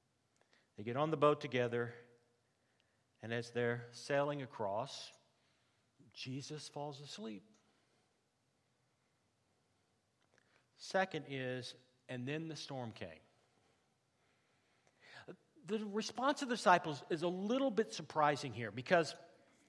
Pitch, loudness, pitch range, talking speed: 130 Hz, -39 LUFS, 120-155 Hz, 100 wpm